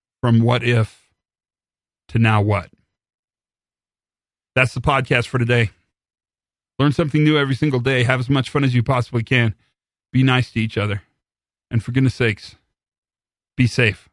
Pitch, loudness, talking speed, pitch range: 125 Hz, -19 LUFS, 155 wpm, 115-135 Hz